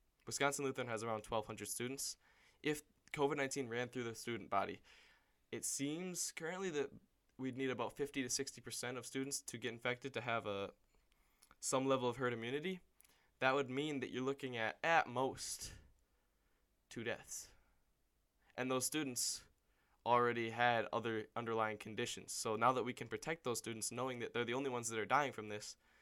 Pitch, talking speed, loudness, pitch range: 120 Hz, 175 wpm, -41 LUFS, 115-135 Hz